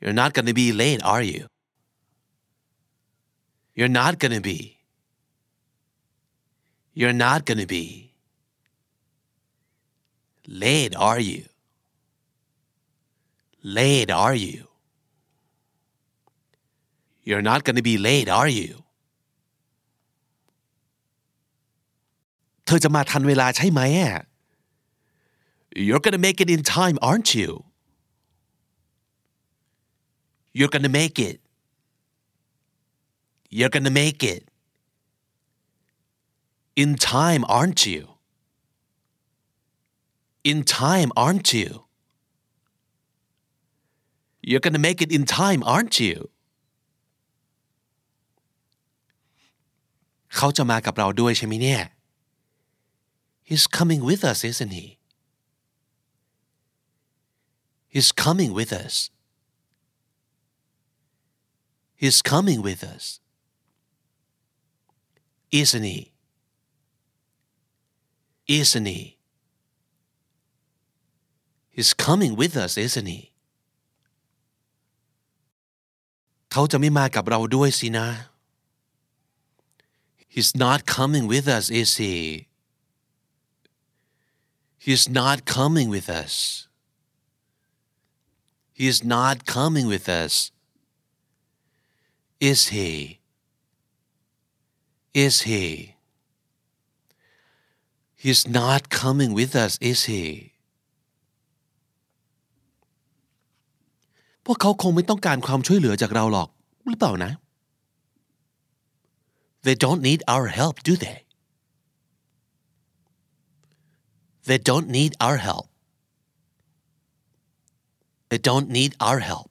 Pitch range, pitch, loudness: 125-145 Hz, 140 Hz, -20 LUFS